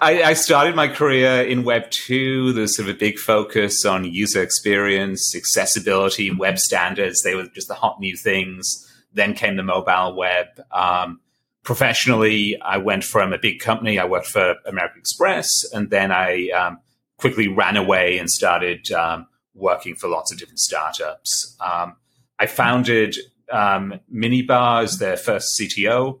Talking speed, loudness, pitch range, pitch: 160 wpm, -19 LUFS, 95-125 Hz, 105 Hz